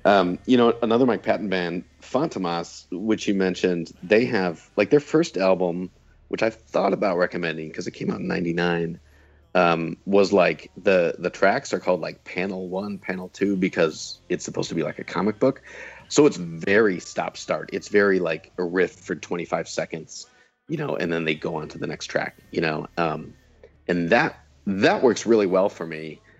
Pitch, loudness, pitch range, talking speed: 90 Hz, -23 LUFS, 85-100 Hz, 195 wpm